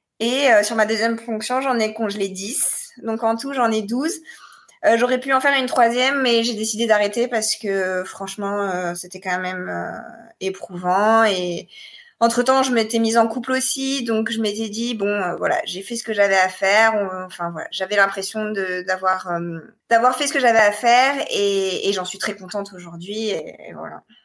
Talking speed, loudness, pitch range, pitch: 205 wpm, -20 LUFS, 195-235 Hz, 220 Hz